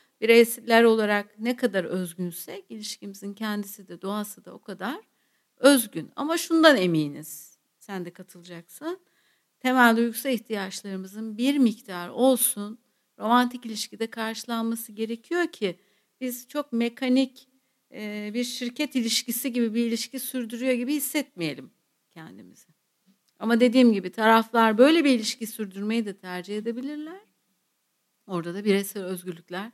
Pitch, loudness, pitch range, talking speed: 225 Hz, -25 LUFS, 200-250 Hz, 120 wpm